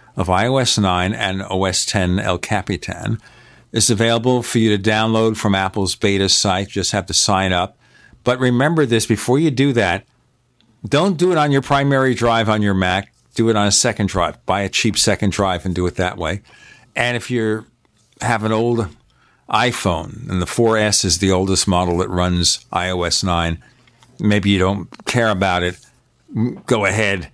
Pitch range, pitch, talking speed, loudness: 95-120 Hz, 105 Hz, 180 wpm, -17 LUFS